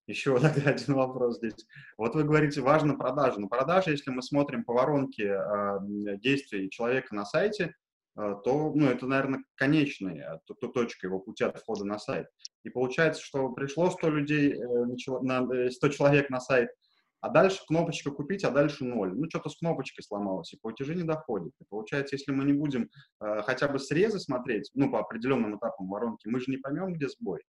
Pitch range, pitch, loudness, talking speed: 120-150 Hz, 135 Hz, -29 LUFS, 175 wpm